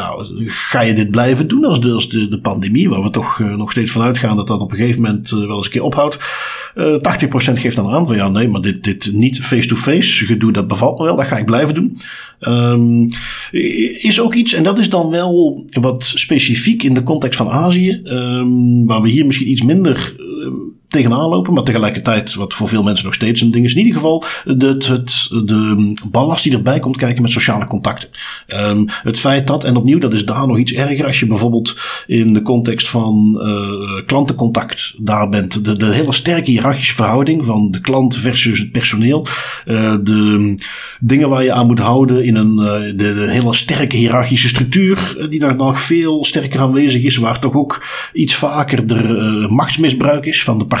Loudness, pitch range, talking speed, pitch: -13 LUFS, 110-140 Hz, 210 wpm, 120 Hz